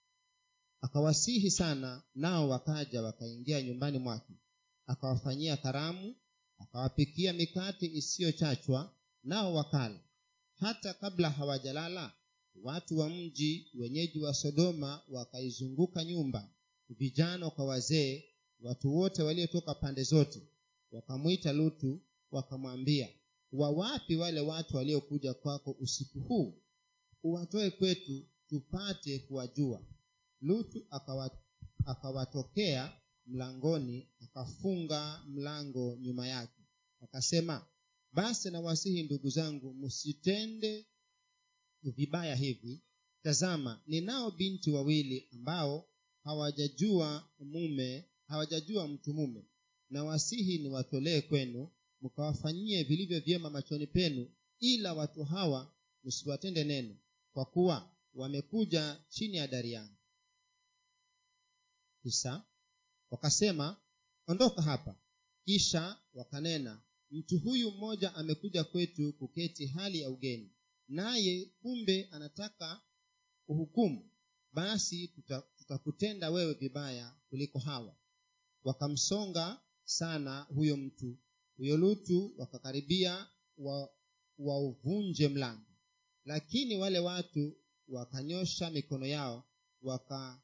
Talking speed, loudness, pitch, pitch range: 90 wpm, -36 LUFS, 155 Hz, 135-195 Hz